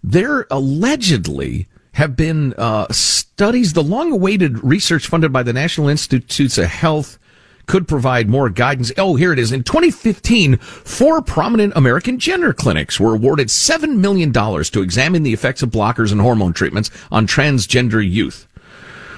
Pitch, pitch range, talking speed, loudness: 140 Hz, 115-180 Hz, 145 wpm, -15 LUFS